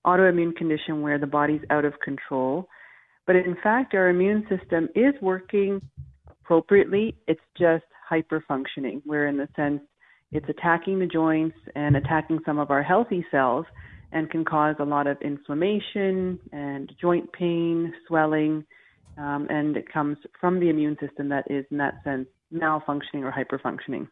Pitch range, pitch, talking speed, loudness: 145-175 Hz, 155 Hz, 155 wpm, -25 LUFS